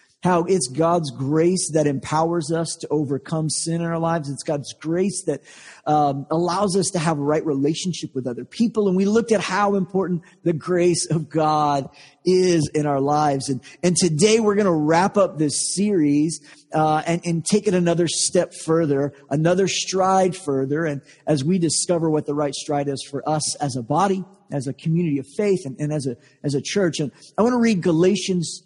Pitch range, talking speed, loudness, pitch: 145-180 Hz, 200 wpm, -21 LUFS, 165 Hz